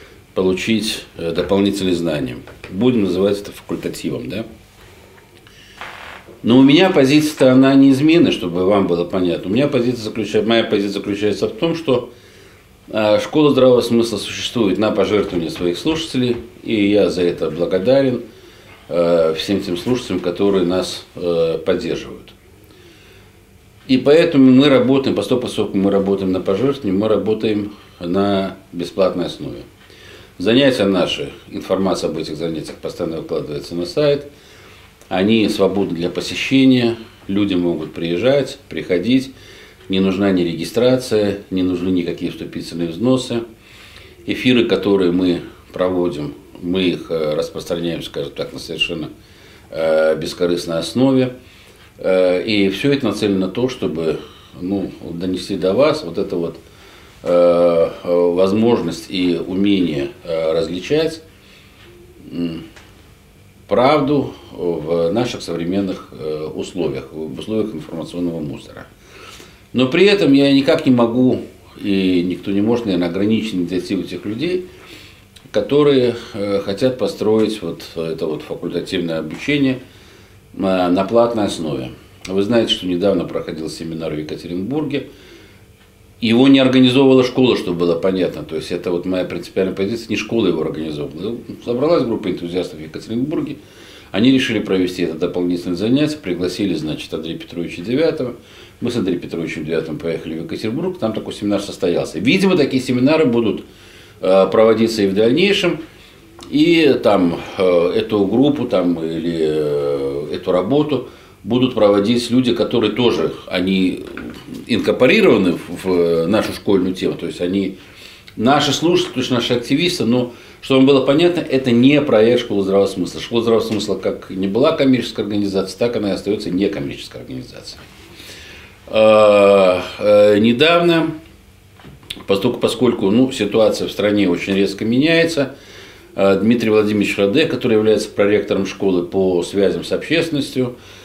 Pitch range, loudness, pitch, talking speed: 90-120 Hz, -17 LUFS, 100 Hz, 125 wpm